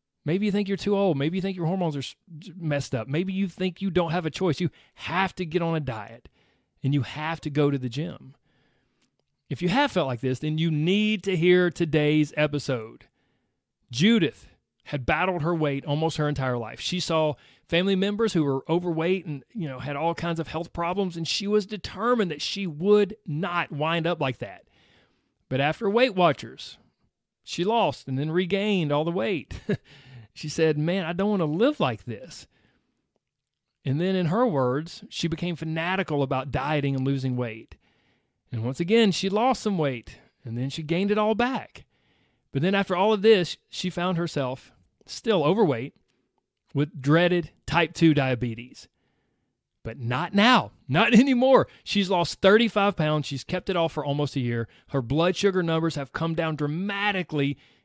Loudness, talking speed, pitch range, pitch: -25 LUFS, 185 wpm, 140-185 Hz, 165 Hz